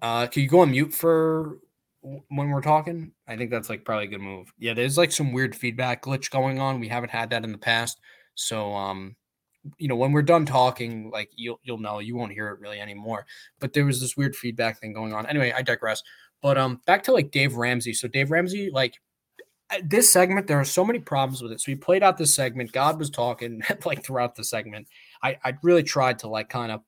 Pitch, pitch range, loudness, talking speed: 130 Hz, 115-145 Hz, -24 LUFS, 235 wpm